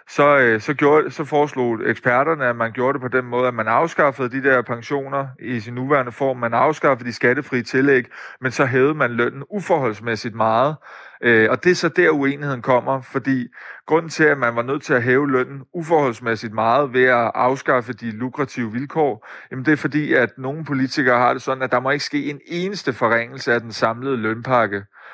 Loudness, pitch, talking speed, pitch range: -19 LUFS, 130 Hz, 200 wpm, 120-145 Hz